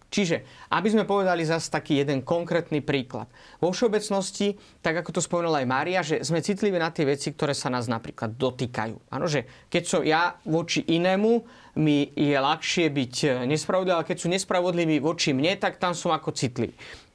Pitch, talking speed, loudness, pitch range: 165 Hz, 180 wpm, -25 LUFS, 145-180 Hz